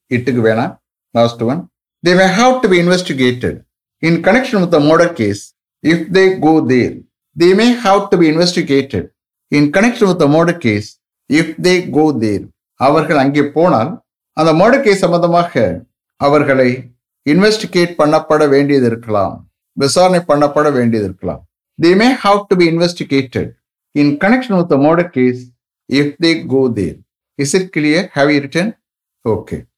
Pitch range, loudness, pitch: 125-180 Hz, -13 LUFS, 155 Hz